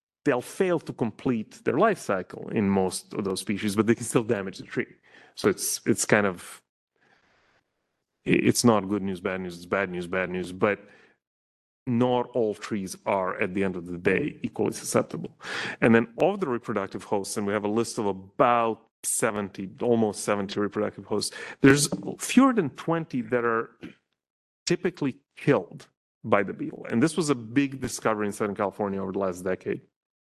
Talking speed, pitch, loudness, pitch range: 180 wpm, 105 Hz, -26 LUFS, 95-125 Hz